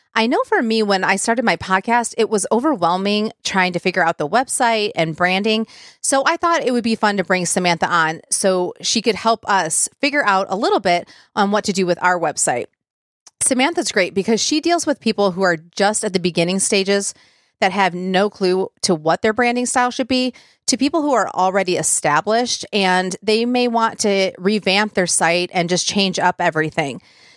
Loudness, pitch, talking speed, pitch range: -17 LUFS, 200 Hz, 200 wpm, 185-230 Hz